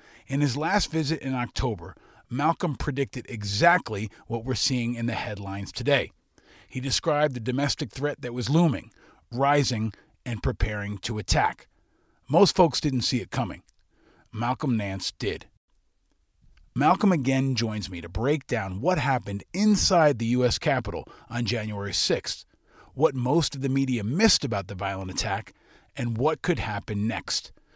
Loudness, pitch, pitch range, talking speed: -26 LUFS, 125 Hz, 110-145 Hz, 150 wpm